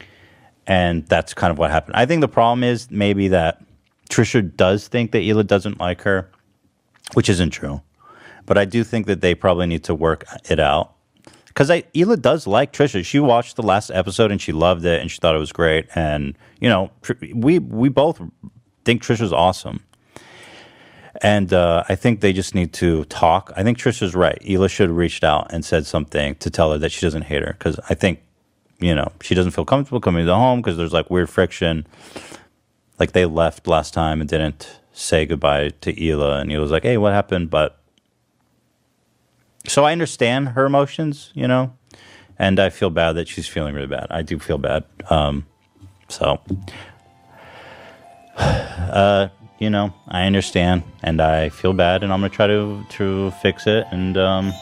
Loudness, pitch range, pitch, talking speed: -19 LUFS, 85-105 Hz, 95 Hz, 190 wpm